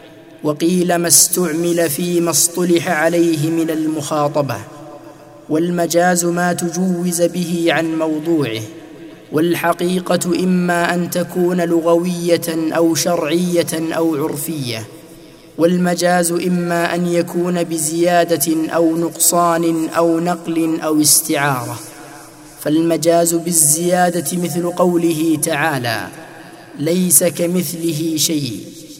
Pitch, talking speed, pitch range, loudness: 165 Hz, 85 wpm, 160-175 Hz, -16 LUFS